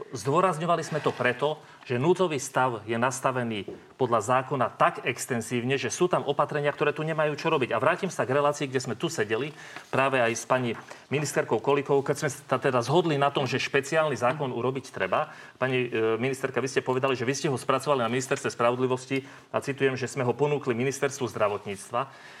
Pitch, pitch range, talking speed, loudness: 135 Hz, 125-145 Hz, 185 wpm, -27 LUFS